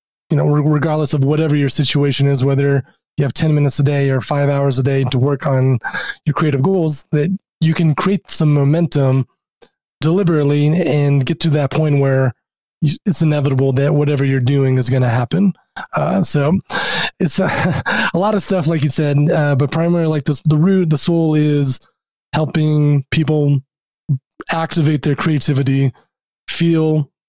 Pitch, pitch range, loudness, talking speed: 150 Hz, 140-160 Hz, -16 LUFS, 165 wpm